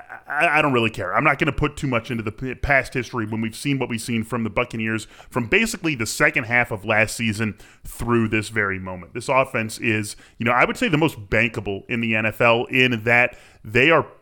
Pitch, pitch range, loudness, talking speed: 115 Hz, 110-130 Hz, -21 LUFS, 230 wpm